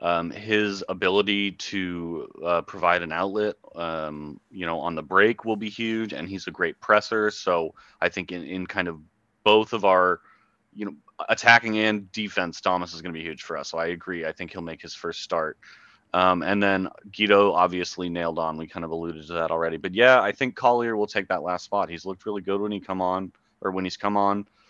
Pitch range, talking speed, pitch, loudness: 85-105 Hz, 225 wpm, 95 Hz, -24 LUFS